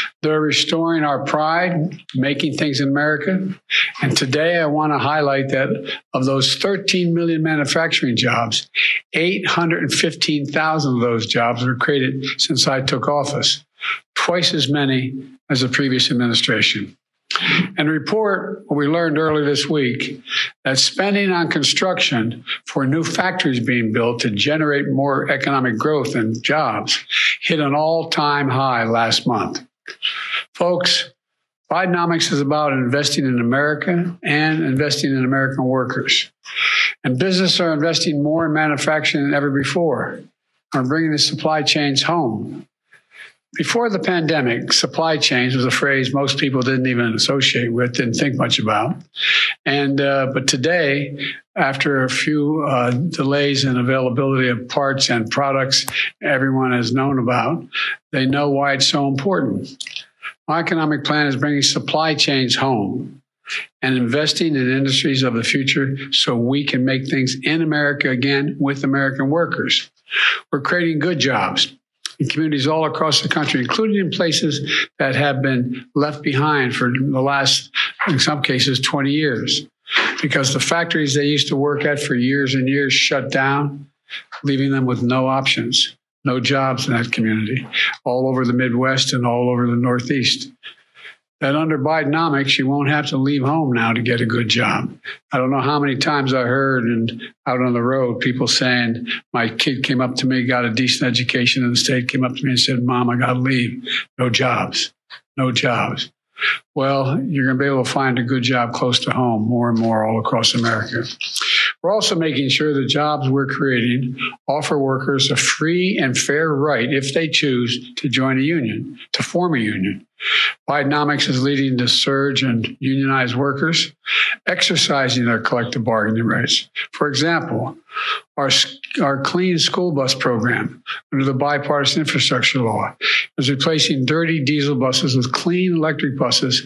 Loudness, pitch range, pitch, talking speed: -18 LUFS, 130-155 Hz, 140 Hz, 160 wpm